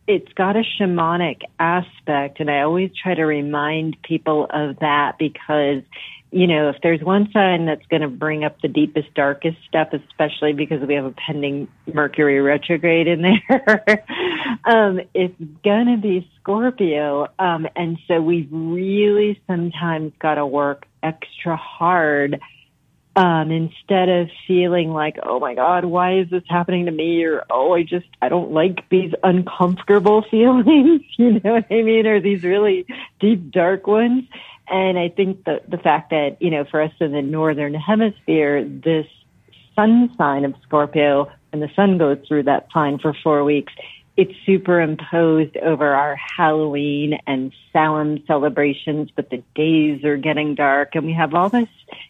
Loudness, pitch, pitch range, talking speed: -18 LUFS, 165 Hz, 150-185 Hz, 160 wpm